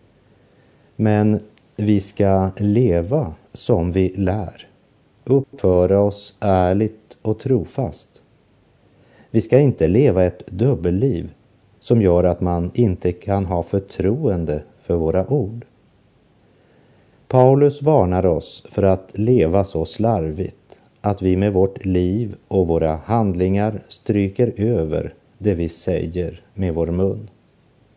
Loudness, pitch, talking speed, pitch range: -19 LUFS, 100 Hz, 115 wpm, 90-115 Hz